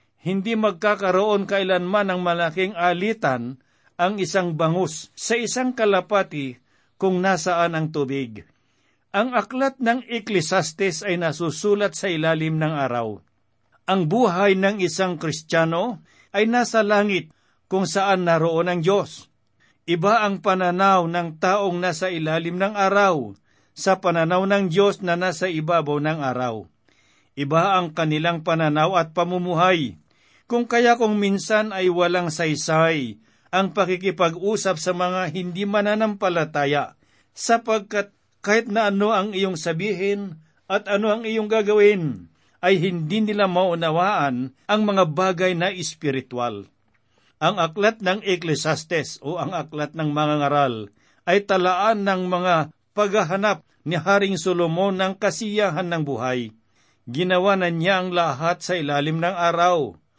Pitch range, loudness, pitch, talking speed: 155-200 Hz, -21 LUFS, 180 Hz, 125 wpm